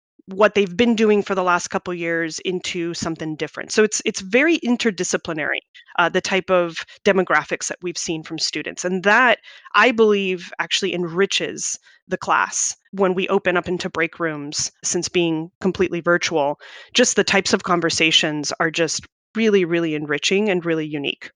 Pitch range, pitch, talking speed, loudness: 165-200 Hz, 180 Hz, 170 wpm, -20 LUFS